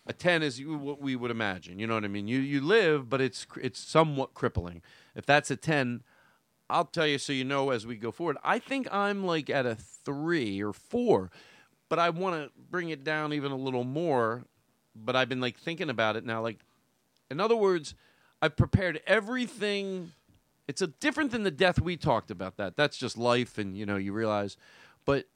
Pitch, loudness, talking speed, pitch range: 135 Hz, -30 LUFS, 210 wpm, 115-170 Hz